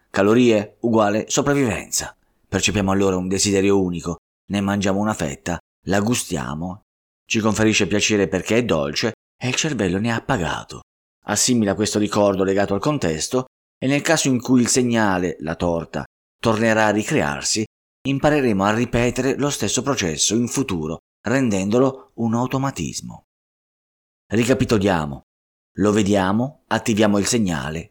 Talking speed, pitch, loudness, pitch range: 130 wpm, 105 Hz, -20 LUFS, 95-120 Hz